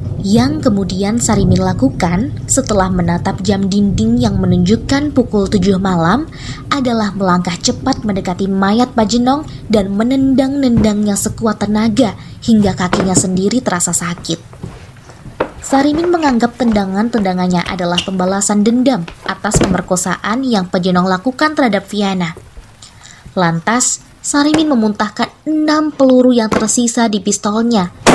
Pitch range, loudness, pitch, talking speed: 185-245 Hz, -14 LUFS, 210 Hz, 105 wpm